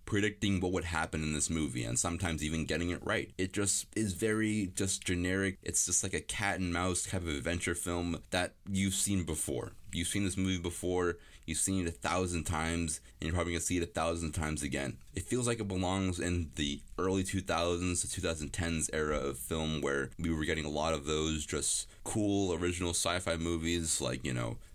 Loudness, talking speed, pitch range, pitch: -34 LUFS, 210 wpm, 80-95 Hz, 85 Hz